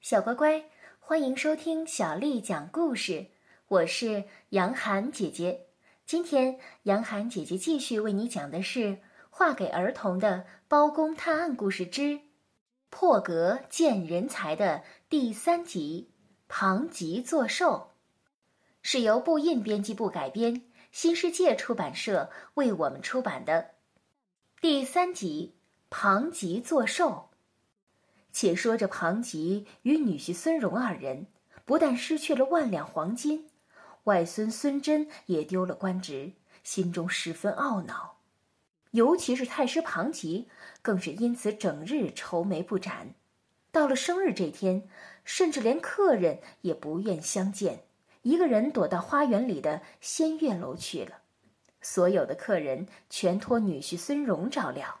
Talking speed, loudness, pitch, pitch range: 195 characters per minute, -29 LUFS, 230 Hz, 190-300 Hz